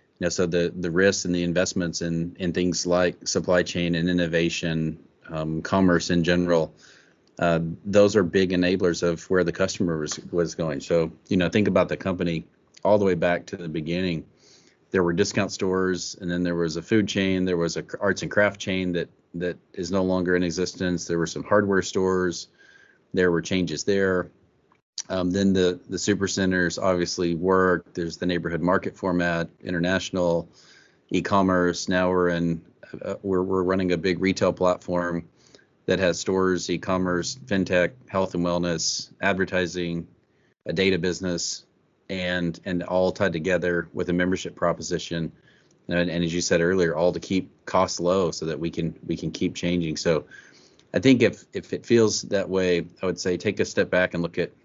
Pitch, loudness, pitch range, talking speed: 90 Hz, -24 LUFS, 85-95 Hz, 180 wpm